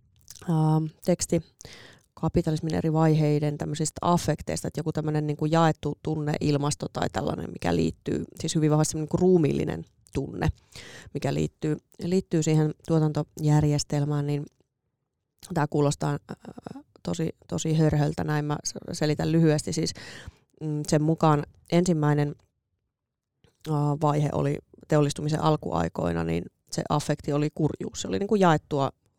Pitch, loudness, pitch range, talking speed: 150 Hz, -26 LUFS, 145-160 Hz, 115 wpm